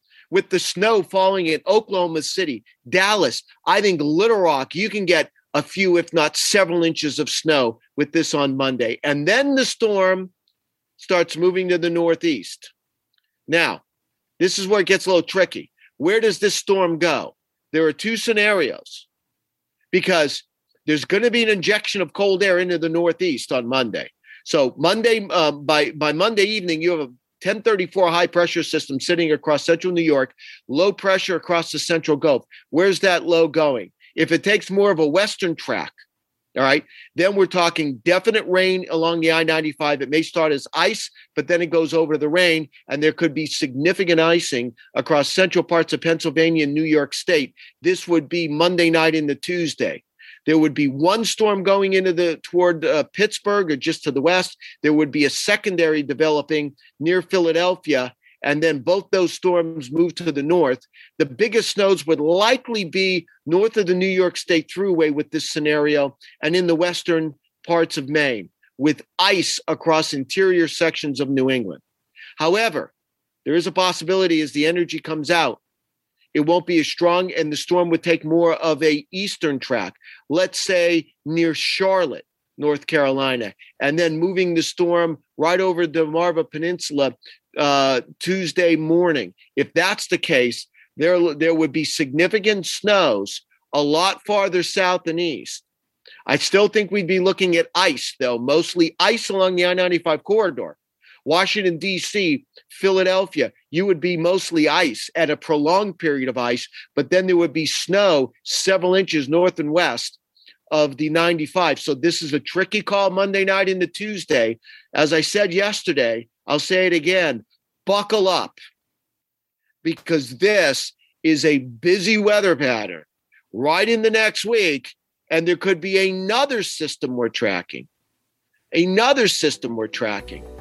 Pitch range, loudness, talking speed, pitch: 155-190 Hz, -19 LUFS, 165 wpm, 170 Hz